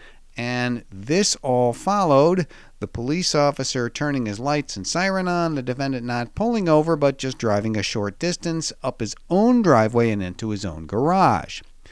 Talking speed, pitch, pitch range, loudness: 165 wpm, 130 Hz, 110-160 Hz, -21 LUFS